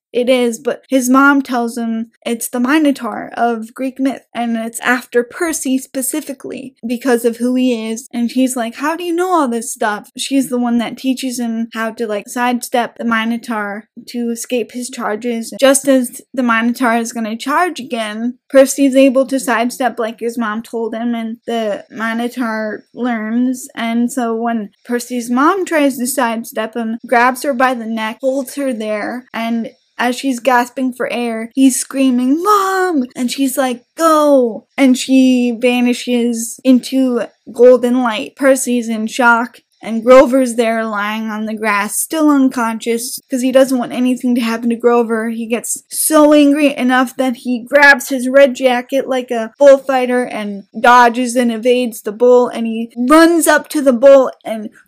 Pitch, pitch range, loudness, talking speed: 245 Hz, 230-265 Hz, -14 LUFS, 170 wpm